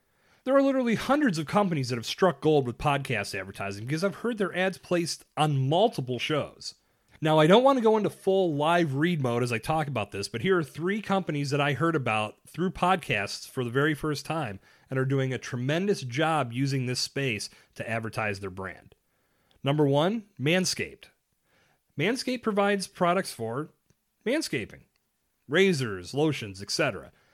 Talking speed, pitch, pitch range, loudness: 170 wpm, 150 Hz, 125-185 Hz, -27 LUFS